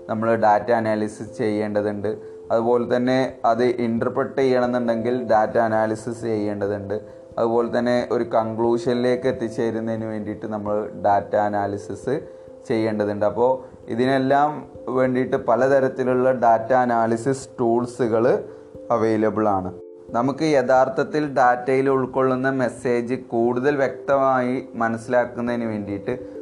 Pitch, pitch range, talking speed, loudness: 120 Hz, 110-130 Hz, 90 wpm, -21 LUFS